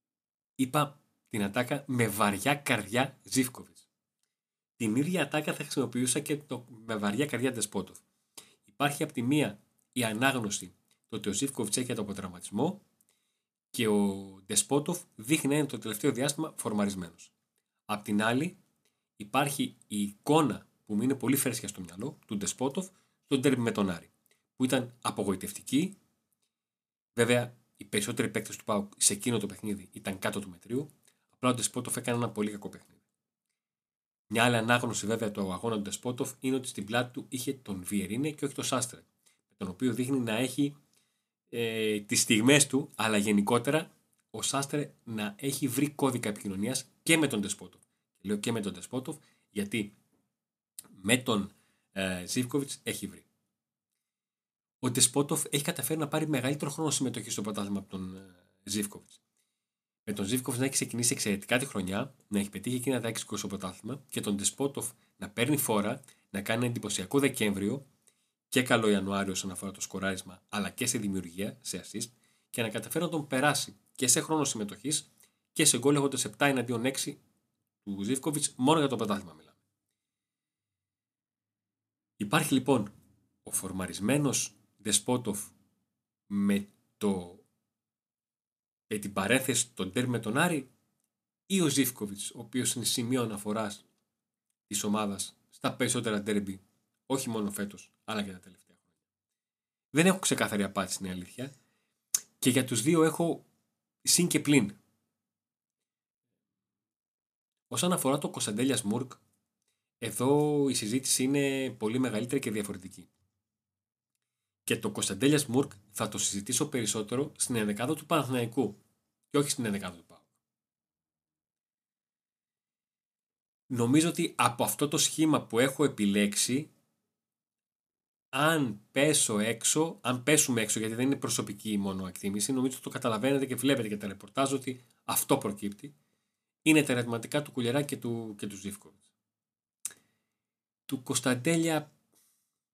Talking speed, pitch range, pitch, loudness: 145 wpm, 105-140 Hz, 120 Hz, -30 LUFS